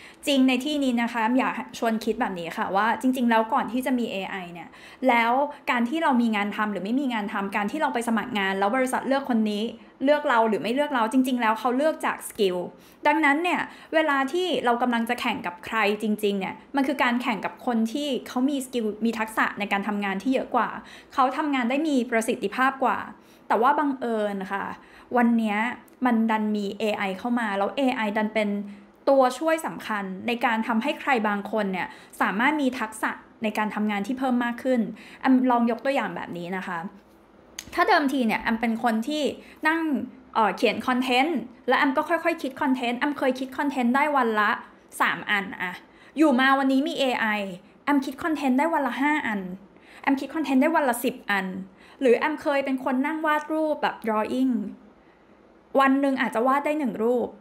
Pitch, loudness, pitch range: 245 Hz, -24 LUFS, 215-275 Hz